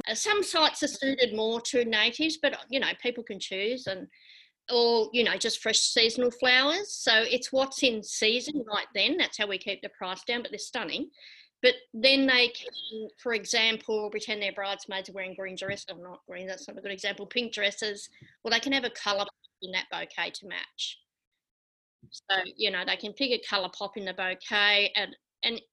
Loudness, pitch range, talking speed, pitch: -27 LUFS, 200-250 Hz, 200 wpm, 220 Hz